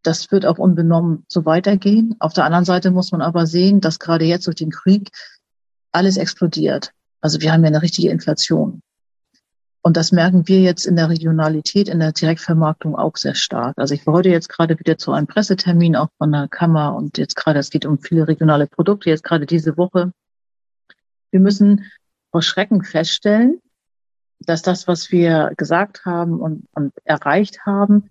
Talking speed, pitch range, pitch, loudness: 180 wpm, 155-185 Hz, 170 Hz, -16 LUFS